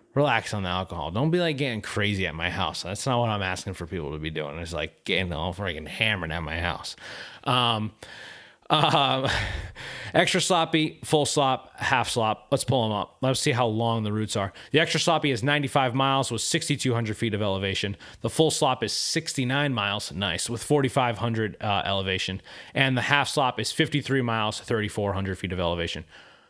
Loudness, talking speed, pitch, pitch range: -25 LUFS, 190 wpm, 115 Hz, 95-135 Hz